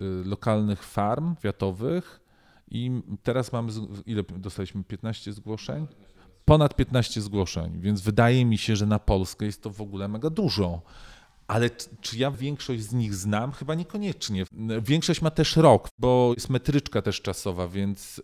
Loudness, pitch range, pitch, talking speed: -26 LUFS, 100-125 Hz, 110 Hz, 150 wpm